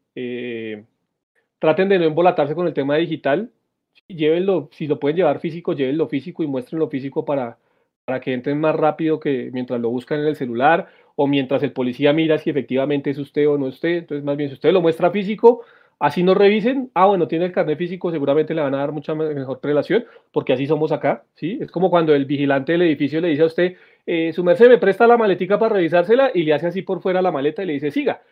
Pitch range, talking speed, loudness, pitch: 140-175 Hz, 230 wpm, -19 LUFS, 155 Hz